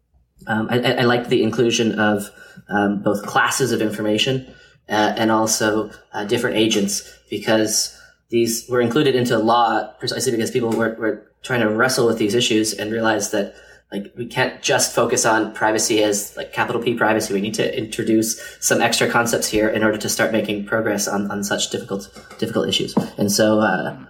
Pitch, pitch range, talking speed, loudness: 110 Hz, 105-115 Hz, 180 wpm, -19 LUFS